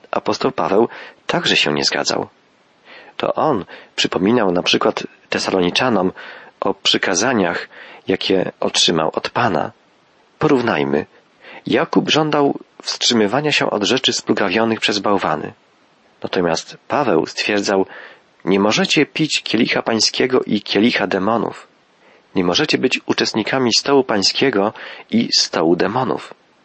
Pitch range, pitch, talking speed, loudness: 100-145 Hz, 120 Hz, 110 wpm, -17 LUFS